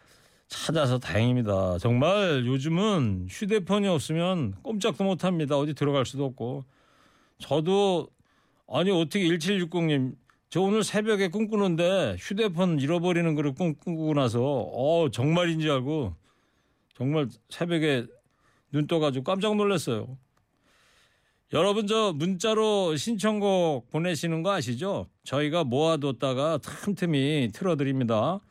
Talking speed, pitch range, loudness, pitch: 265 characters per minute, 135-190 Hz, -26 LUFS, 160 Hz